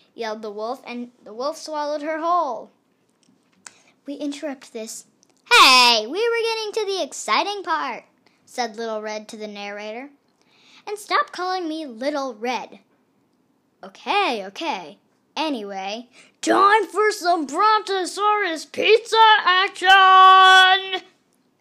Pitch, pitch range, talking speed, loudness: 315 Hz, 245-385 Hz, 115 wpm, -18 LUFS